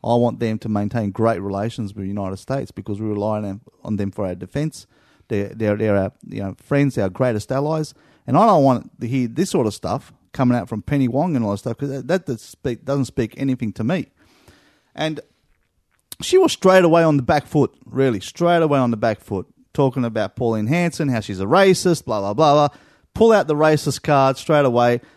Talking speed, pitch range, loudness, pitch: 220 wpm, 105-145 Hz, -20 LUFS, 125 Hz